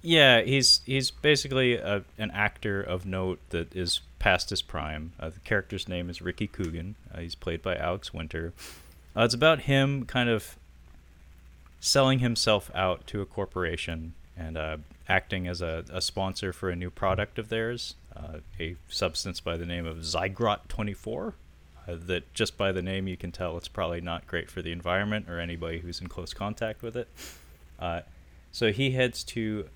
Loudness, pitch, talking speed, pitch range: -28 LUFS, 90 Hz, 180 wpm, 80-105 Hz